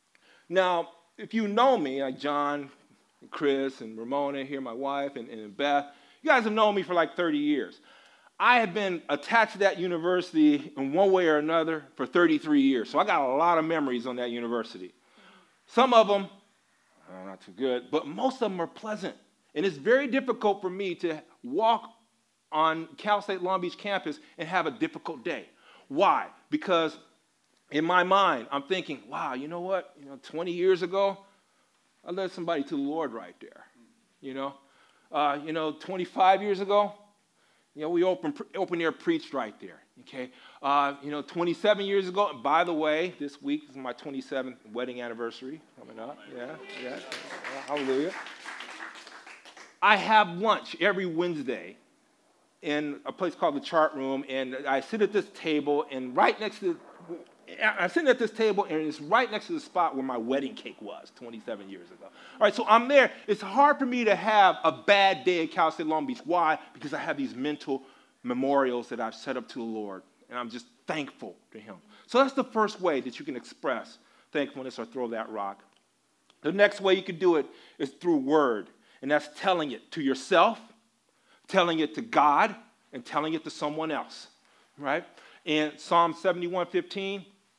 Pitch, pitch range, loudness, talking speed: 175 Hz, 145-210 Hz, -27 LUFS, 190 wpm